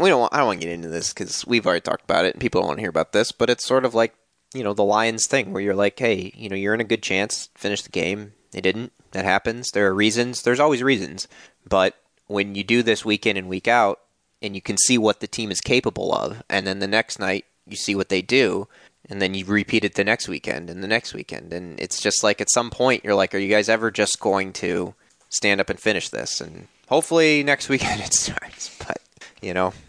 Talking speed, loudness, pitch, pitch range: 260 wpm, -21 LUFS, 105 Hz, 95-120 Hz